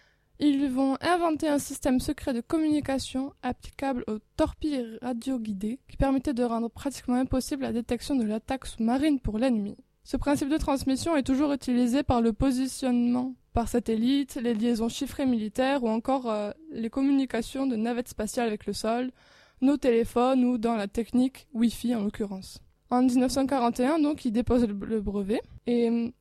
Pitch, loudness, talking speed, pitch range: 250 Hz, -27 LUFS, 160 wpm, 235-275 Hz